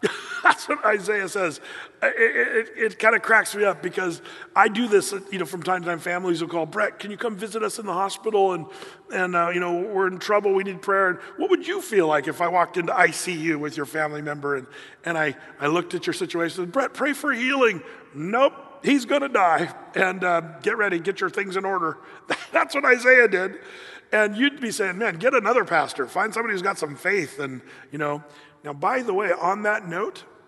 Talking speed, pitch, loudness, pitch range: 225 wpm, 195 Hz, -23 LUFS, 175-265 Hz